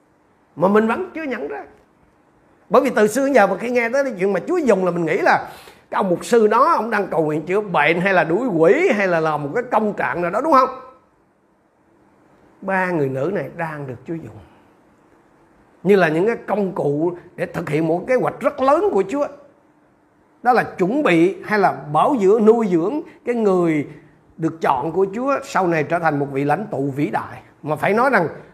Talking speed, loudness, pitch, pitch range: 220 wpm, -18 LUFS, 190 Hz, 160-245 Hz